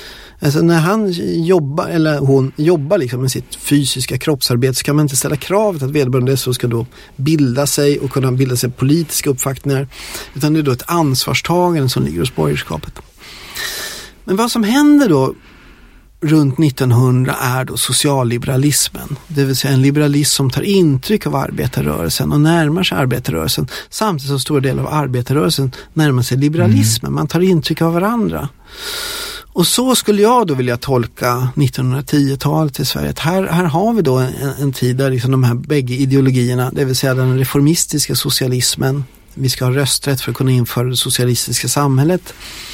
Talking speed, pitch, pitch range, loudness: 165 wpm, 140 Hz, 130-160 Hz, -15 LUFS